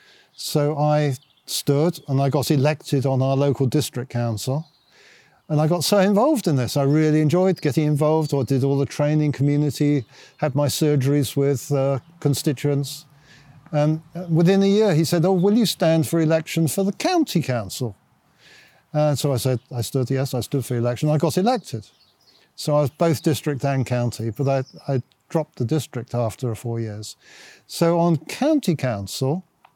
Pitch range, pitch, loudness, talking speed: 135-160 Hz, 145 Hz, -21 LUFS, 175 wpm